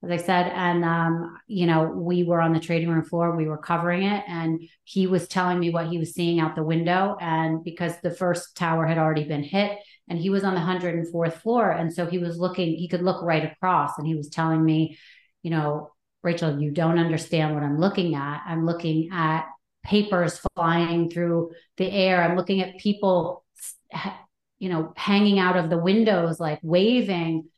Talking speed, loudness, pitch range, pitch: 200 wpm, -24 LUFS, 160-180 Hz, 170 Hz